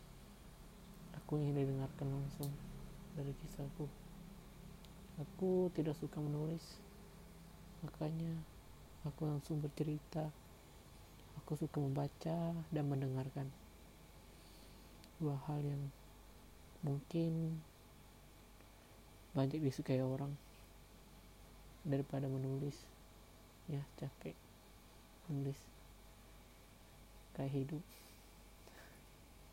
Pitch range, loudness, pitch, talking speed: 135-165 Hz, -43 LUFS, 145 Hz, 65 wpm